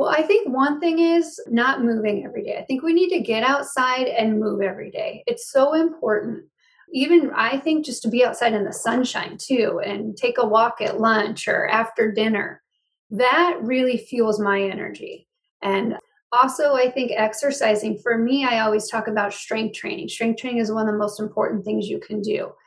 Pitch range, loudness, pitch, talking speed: 215-280 Hz, -21 LUFS, 235 Hz, 195 wpm